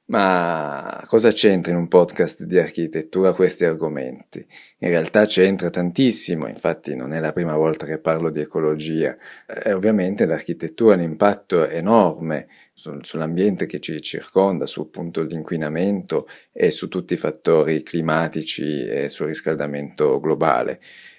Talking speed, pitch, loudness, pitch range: 140 wpm, 85 Hz, -20 LUFS, 80-95 Hz